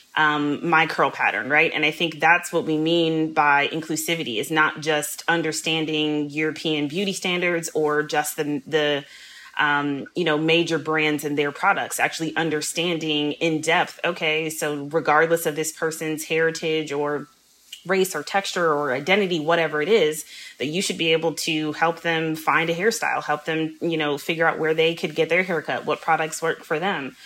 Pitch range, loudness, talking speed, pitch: 150-165 Hz, -22 LUFS, 180 wpm, 160 Hz